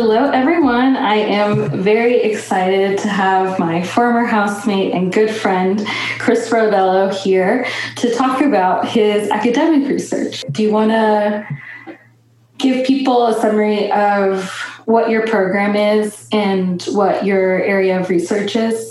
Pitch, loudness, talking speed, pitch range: 210 Hz, -15 LUFS, 135 wpm, 195-230 Hz